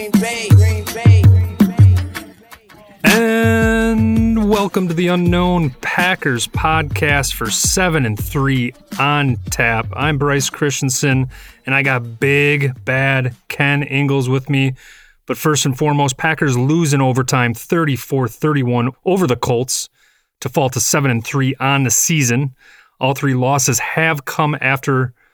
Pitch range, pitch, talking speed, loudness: 125-155 Hz, 135 Hz, 125 wpm, -15 LUFS